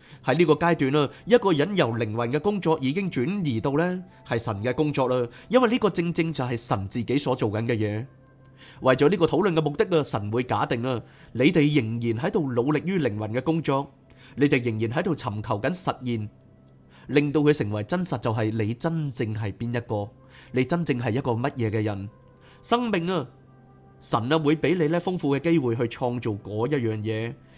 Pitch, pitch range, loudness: 130 Hz, 115-155 Hz, -25 LUFS